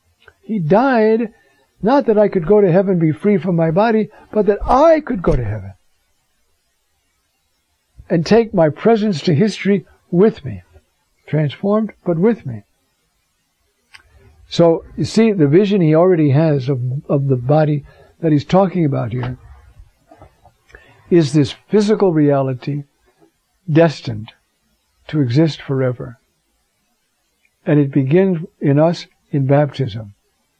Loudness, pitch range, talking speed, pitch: -16 LUFS, 135-200 Hz, 130 wpm, 160 Hz